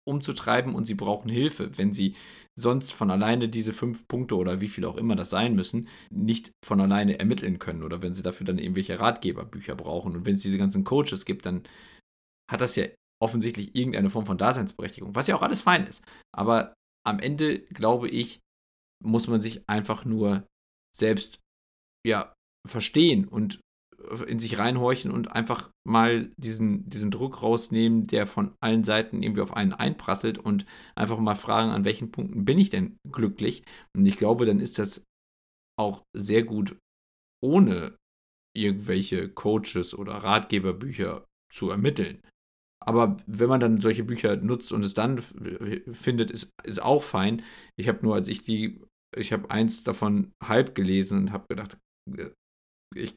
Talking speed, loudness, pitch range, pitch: 165 wpm, -26 LUFS, 95-120 Hz, 110 Hz